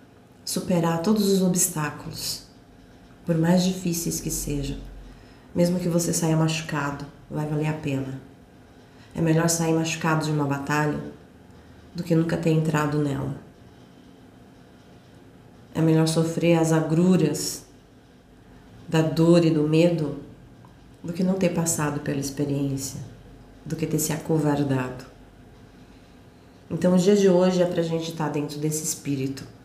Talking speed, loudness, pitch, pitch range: 135 wpm, -24 LUFS, 155 Hz, 140-165 Hz